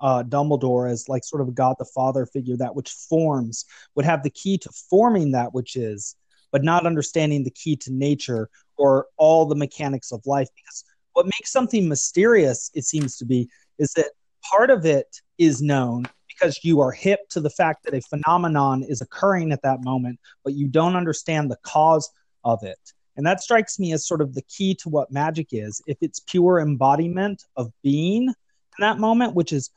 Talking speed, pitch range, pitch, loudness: 200 wpm, 130-170 Hz, 145 Hz, -22 LUFS